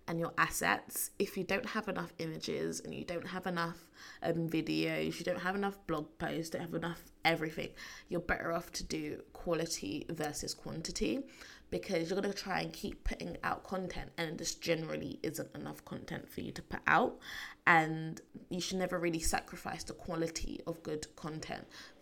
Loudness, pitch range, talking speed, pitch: -37 LUFS, 160-185 Hz, 175 wpm, 170 Hz